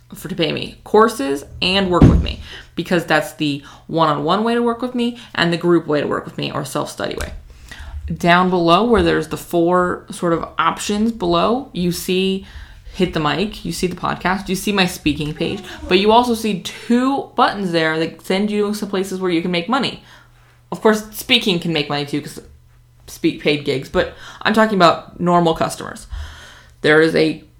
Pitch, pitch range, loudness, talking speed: 175 Hz, 150-200 Hz, -18 LUFS, 200 wpm